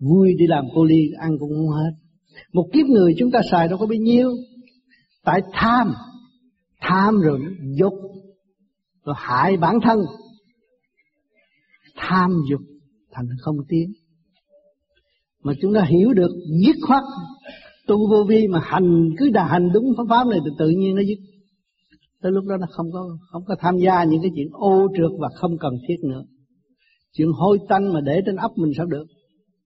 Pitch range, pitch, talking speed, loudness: 160-215 Hz, 185 Hz, 180 wpm, -19 LUFS